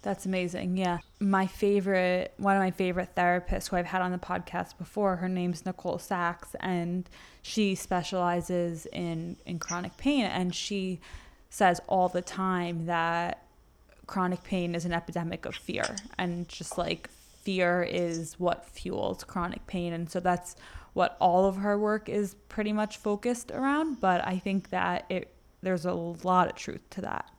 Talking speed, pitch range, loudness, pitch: 165 wpm, 175-195 Hz, -30 LUFS, 180 Hz